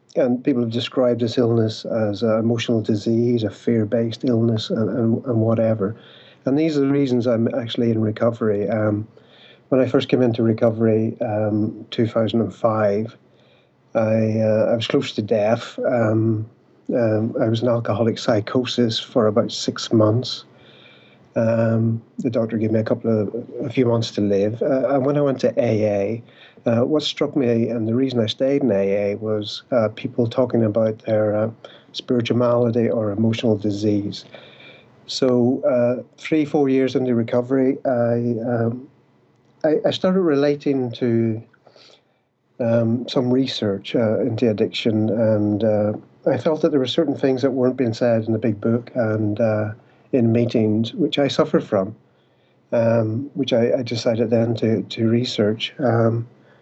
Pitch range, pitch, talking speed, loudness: 110-125 Hz, 115 Hz, 160 wpm, -20 LUFS